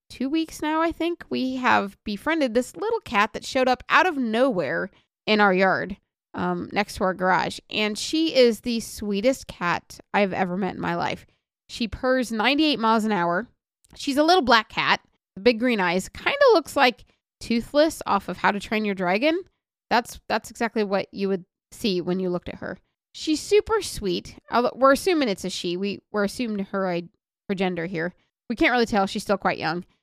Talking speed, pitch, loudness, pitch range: 200 wpm, 220 Hz, -23 LUFS, 190-270 Hz